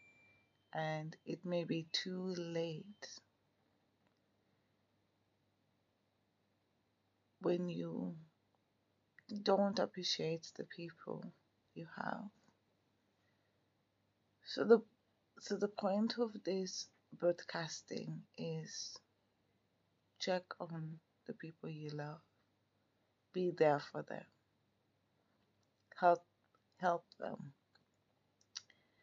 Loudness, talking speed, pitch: -40 LUFS, 75 wpm, 145 Hz